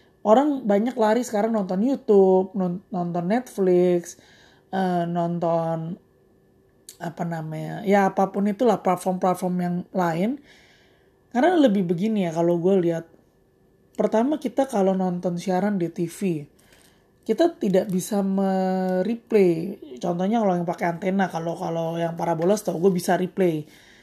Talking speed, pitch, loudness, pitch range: 120 wpm, 185 Hz, -23 LUFS, 175-205 Hz